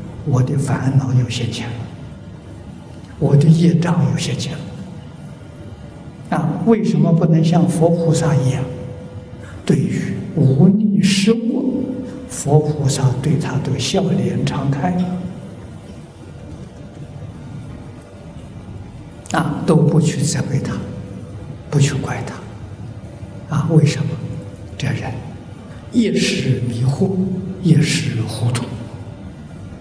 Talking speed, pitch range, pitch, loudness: 135 characters per minute, 125-170 Hz, 150 Hz, -17 LUFS